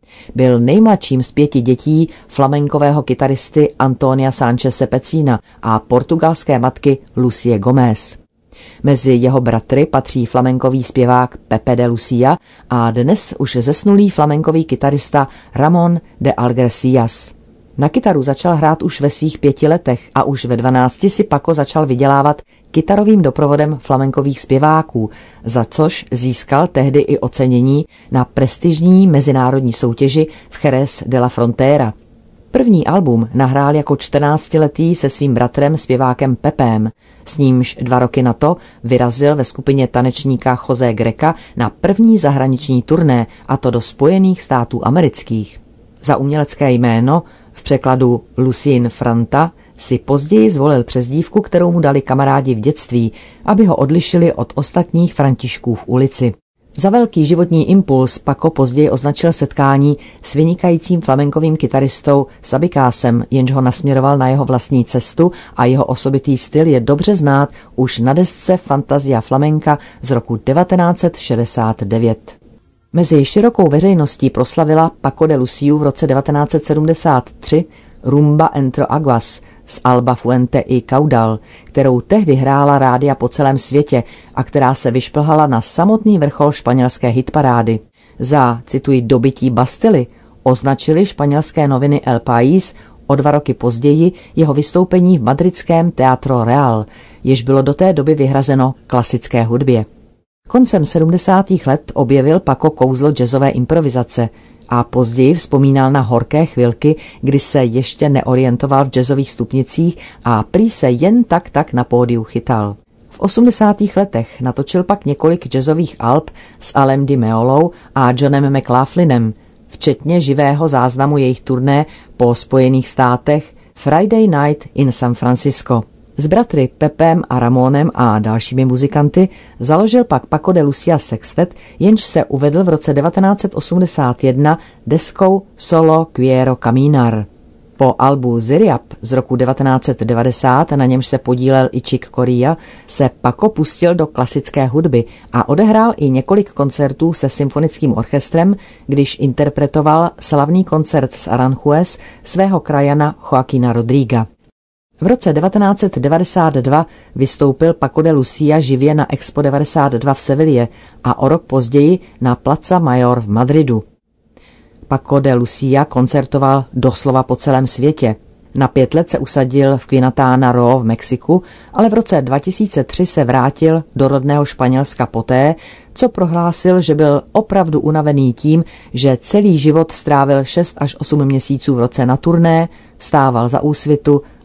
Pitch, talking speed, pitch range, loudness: 140 Hz, 135 wpm, 125-155 Hz, -13 LUFS